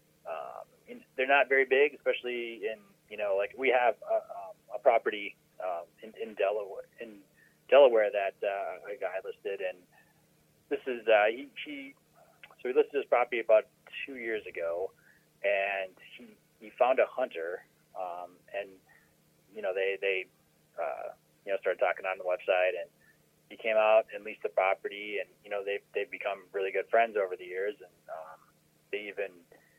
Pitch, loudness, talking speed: 330 Hz, -31 LUFS, 175 wpm